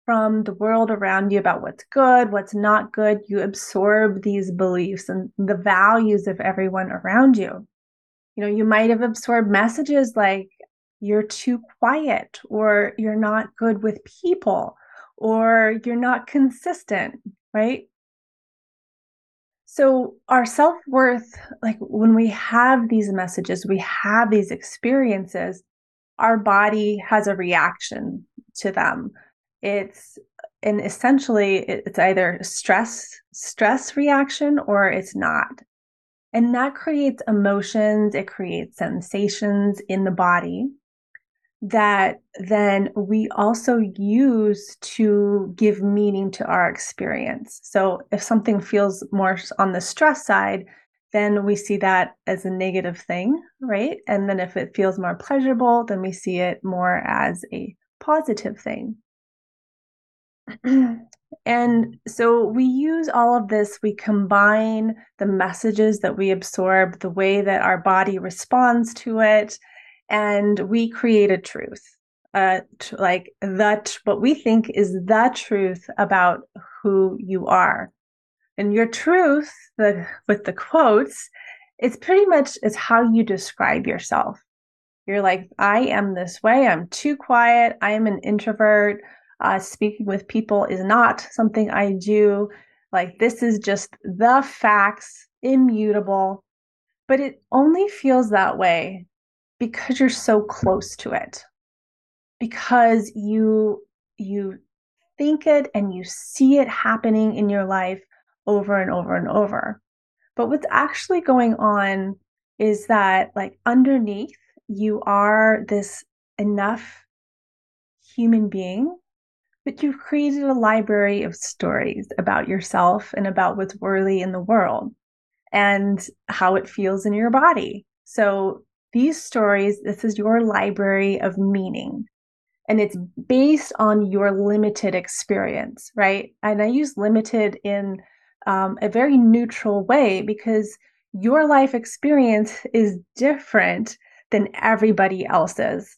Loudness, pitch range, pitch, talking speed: -20 LUFS, 200-240 Hz, 215 Hz, 130 wpm